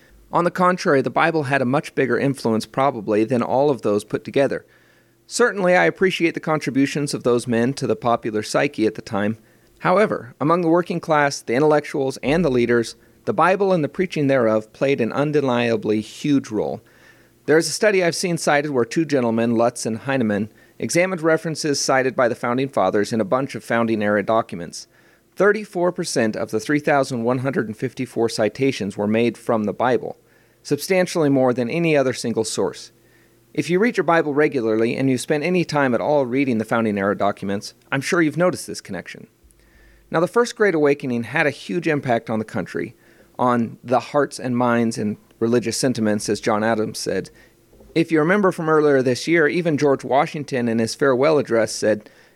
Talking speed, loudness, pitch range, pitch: 185 wpm, -20 LUFS, 115-155 Hz, 135 Hz